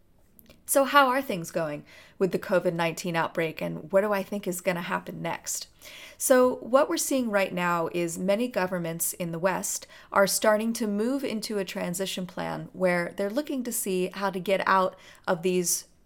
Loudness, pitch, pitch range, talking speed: -27 LUFS, 190 Hz, 180-215 Hz, 190 wpm